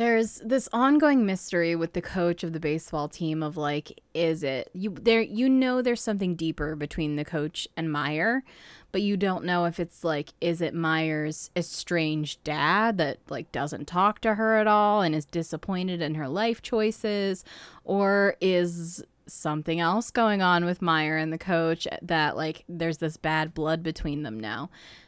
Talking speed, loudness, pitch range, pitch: 175 wpm, -26 LUFS, 155-200 Hz, 170 Hz